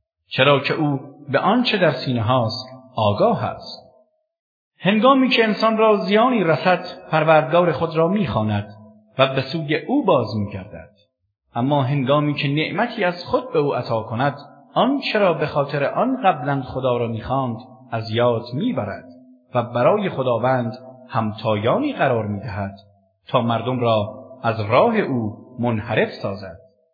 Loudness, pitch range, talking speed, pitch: -20 LUFS, 115-170 Hz, 140 wpm, 130 Hz